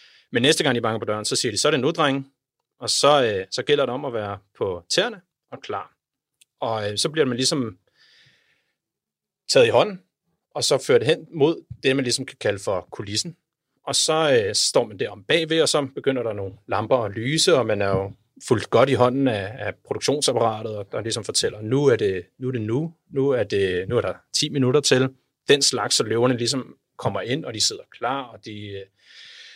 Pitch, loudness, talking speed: 135 Hz, -22 LUFS, 220 wpm